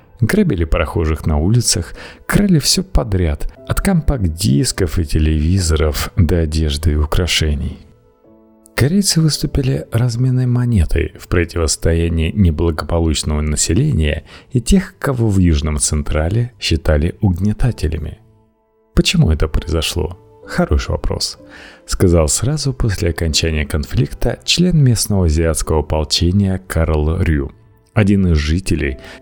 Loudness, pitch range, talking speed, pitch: -16 LUFS, 80-110 Hz, 105 wpm, 90 Hz